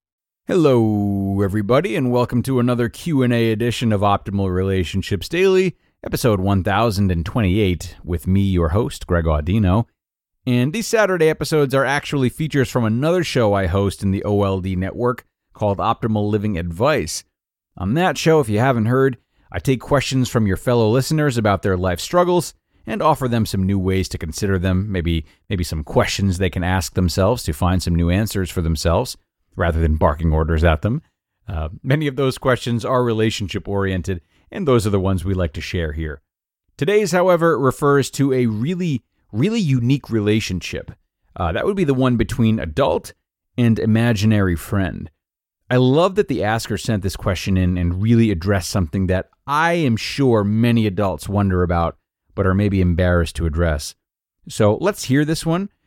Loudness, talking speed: -19 LUFS, 170 wpm